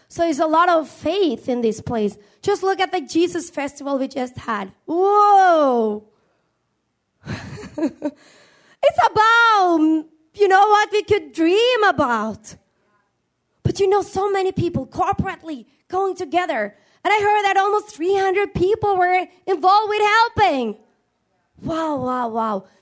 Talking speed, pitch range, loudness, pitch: 135 wpm, 280-395 Hz, -19 LUFS, 350 Hz